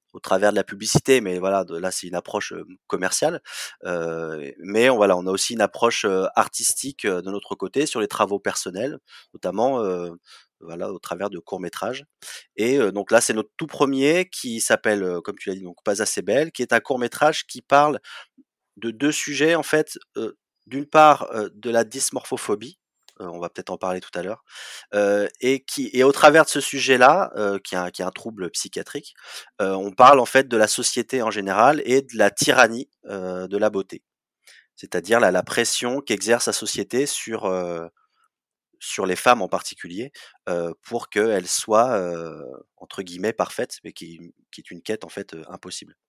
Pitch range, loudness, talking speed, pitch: 95-135 Hz, -21 LUFS, 195 wpm, 110 Hz